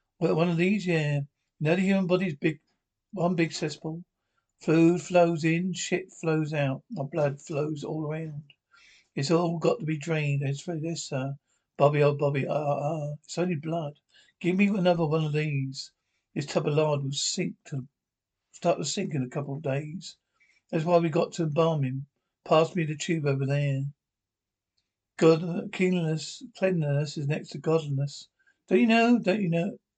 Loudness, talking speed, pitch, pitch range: -27 LUFS, 190 wpm, 160 Hz, 145-175 Hz